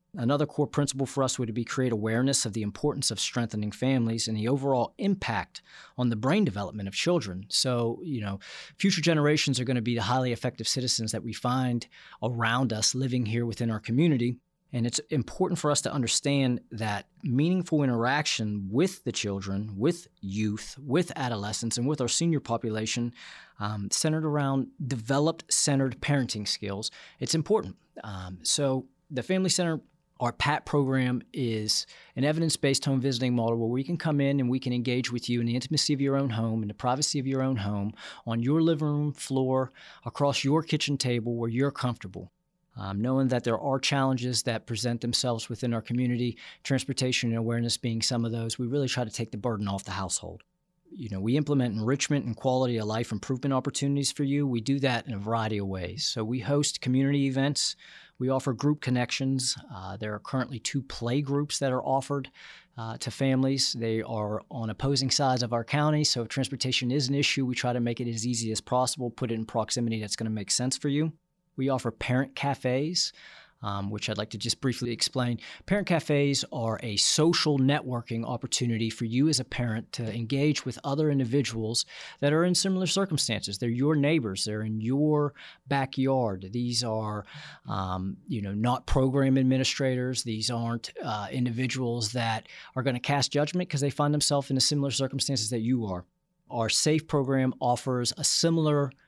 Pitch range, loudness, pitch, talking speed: 115-140 Hz, -28 LUFS, 125 Hz, 190 wpm